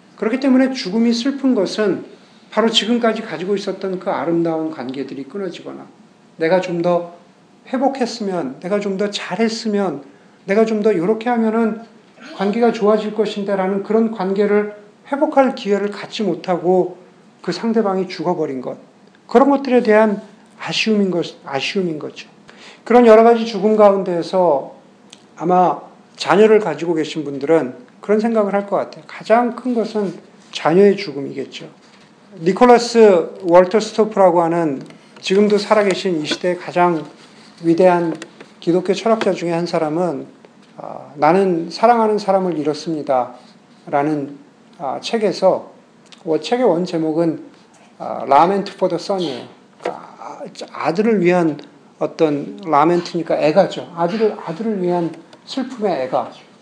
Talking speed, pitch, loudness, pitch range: 290 characters per minute, 200 Hz, -17 LUFS, 170-225 Hz